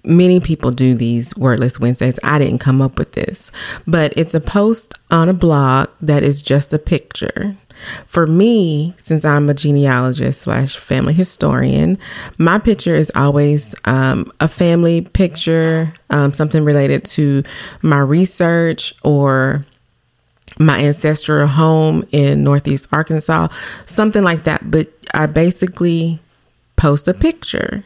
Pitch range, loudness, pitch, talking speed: 135-170 Hz, -14 LUFS, 155 Hz, 135 wpm